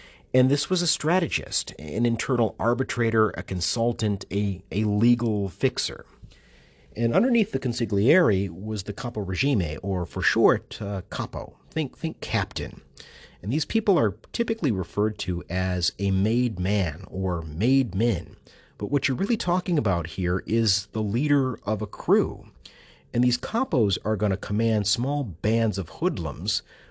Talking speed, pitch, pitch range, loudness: 150 wpm, 110 Hz, 95-130 Hz, -25 LUFS